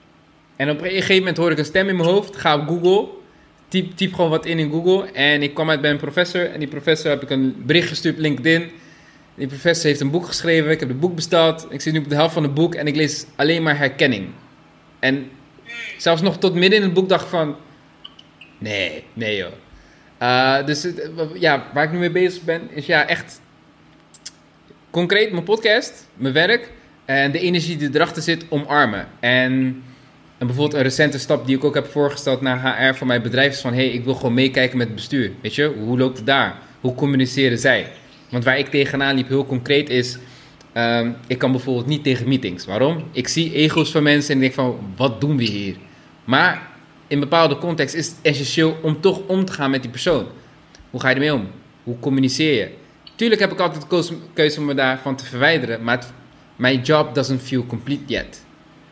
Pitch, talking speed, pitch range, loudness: 145 Hz, 210 wpm, 130-165 Hz, -19 LUFS